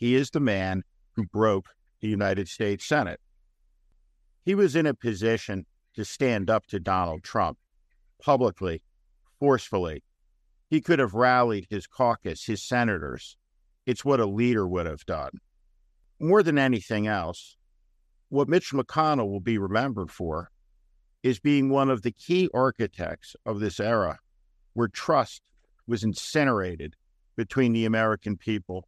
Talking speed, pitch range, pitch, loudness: 140 wpm, 80-125 Hz, 105 Hz, -26 LUFS